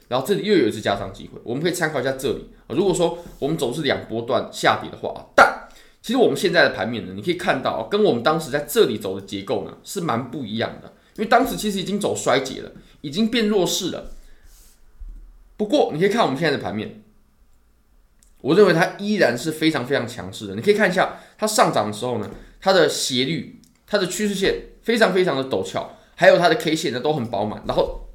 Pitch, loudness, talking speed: 165 Hz, -21 LUFS, 345 characters per minute